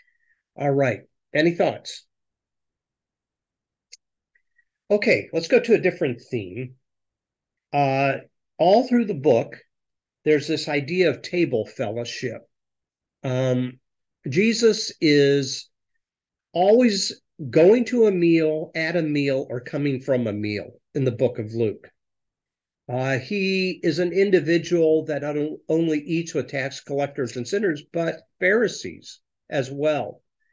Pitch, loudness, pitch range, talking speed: 155 Hz, -22 LUFS, 135-185 Hz, 120 wpm